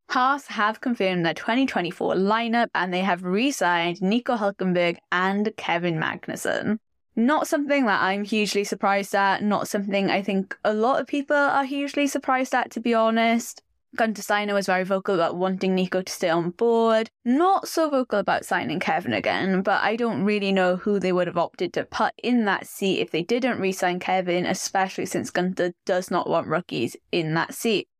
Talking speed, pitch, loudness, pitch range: 190 wpm, 200 Hz, -23 LUFS, 185-235 Hz